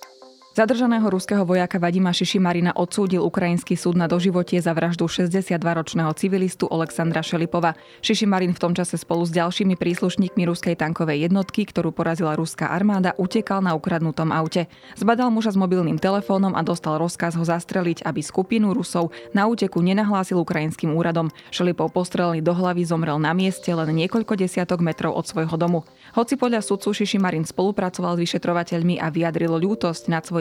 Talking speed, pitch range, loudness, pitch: 150 wpm, 165-190 Hz, -22 LUFS, 175 Hz